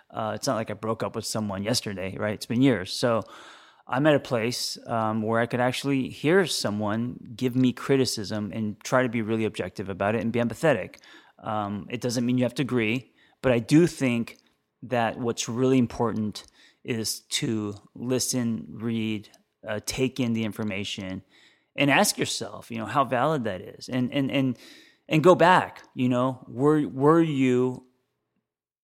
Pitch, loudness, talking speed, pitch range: 120 Hz, -26 LUFS, 175 wpm, 110-130 Hz